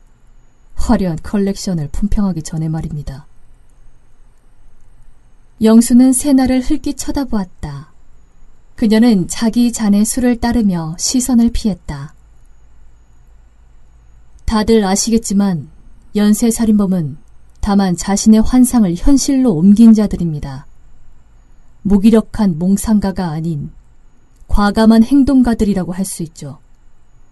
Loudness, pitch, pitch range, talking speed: -13 LUFS, 200 Hz, 155-225 Hz, 225 characters per minute